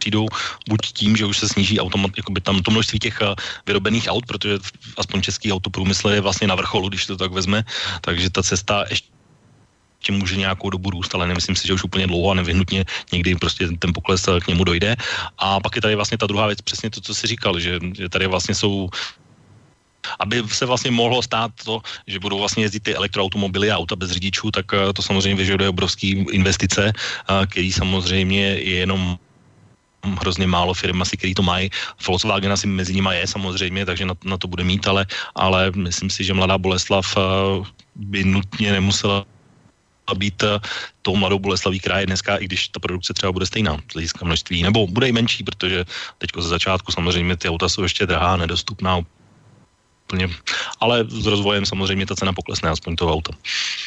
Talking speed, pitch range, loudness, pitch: 190 wpm, 95-105 Hz, -20 LUFS, 95 Hz